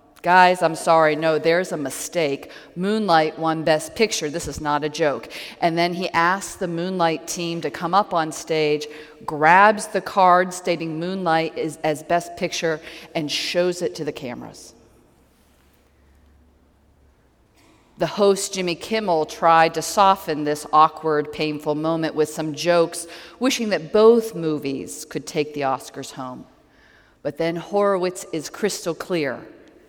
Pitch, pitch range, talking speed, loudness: 165 Hz, 150-180 Hz, 145 wpm, -21 LUFS